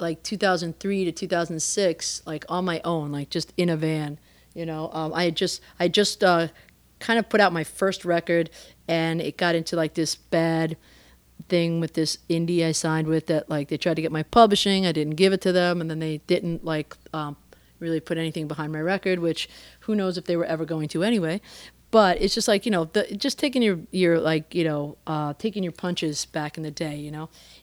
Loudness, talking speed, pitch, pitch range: -24 LUFS, 220 wpm, 165 Hz, 160-185 Hz